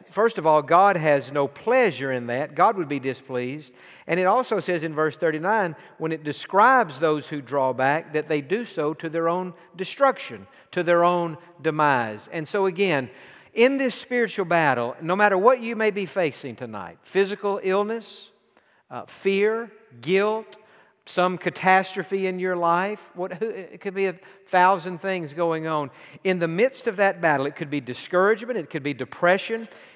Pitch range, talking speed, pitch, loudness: 150-200 Hz, 175 wpm, 180 Hz, -23 LUFS